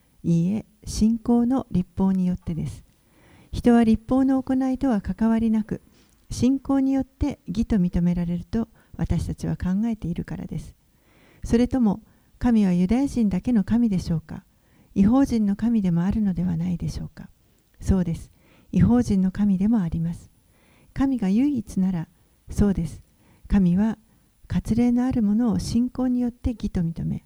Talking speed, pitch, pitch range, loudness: 305 characters per minute, 215 Hz, 180-240 Hz, -23 LUFS